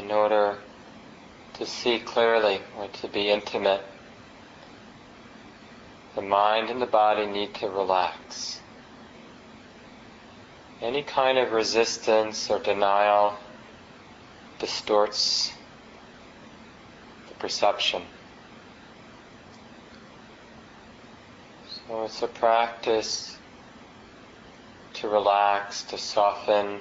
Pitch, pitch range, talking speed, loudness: 105 Hz, 100-115 Hz, 75 wpm, -25 LUFS